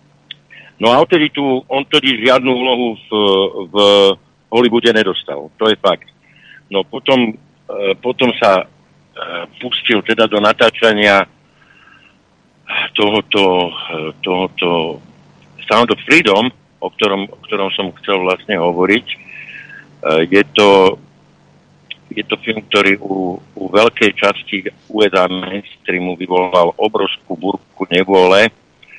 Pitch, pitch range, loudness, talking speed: 100 Hz, 95-120 Hz, -14 LUFS, 110 wpm